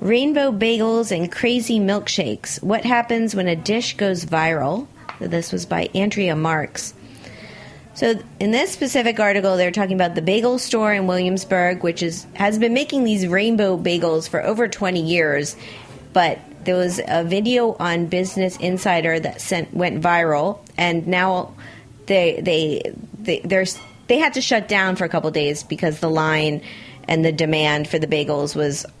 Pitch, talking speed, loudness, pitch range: 180 Hz, 165 wpm, -20 LUFS, 165-210 Hz